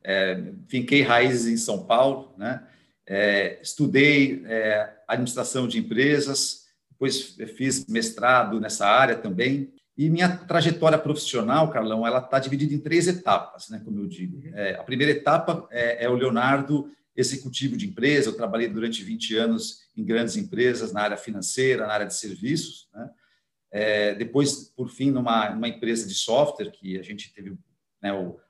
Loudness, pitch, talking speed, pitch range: -24 LUFS, 130 Hz, 160 wpm, 115-150 Hz